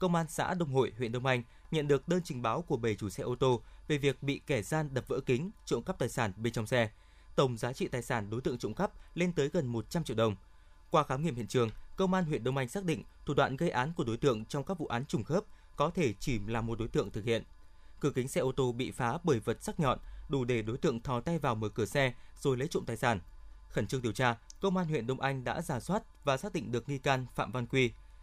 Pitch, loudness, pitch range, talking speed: 130 Hz, -33 LUFS, 115-150 Hz, 275 wpm